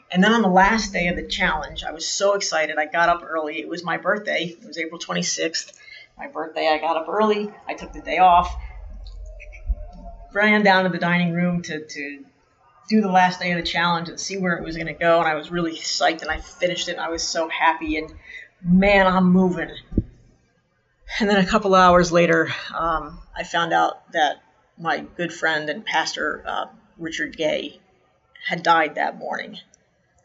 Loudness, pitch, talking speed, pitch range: -21 LUFS, 170 Hz, 200 wpm, 155-185 Hz